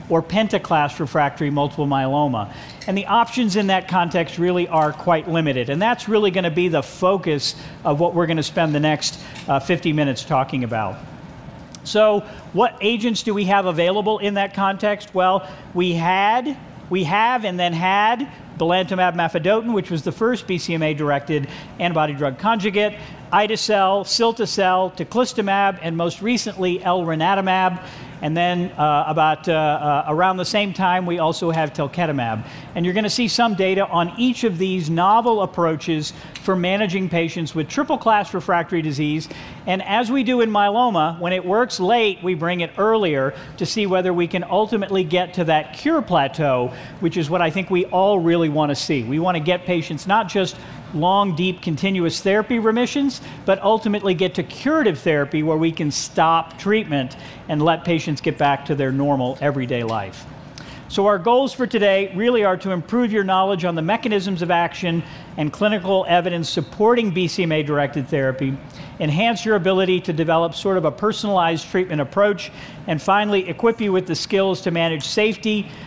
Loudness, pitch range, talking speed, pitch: -20 LUFS, 155-200 Hz, 175 wpm, 180 Hz